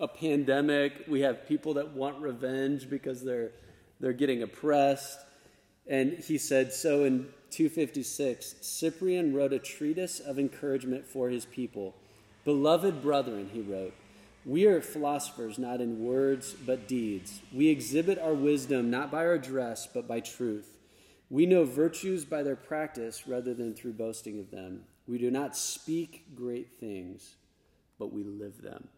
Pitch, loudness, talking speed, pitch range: 135 Hz, -31 LUFS, 150 wpm, 115-145 Hz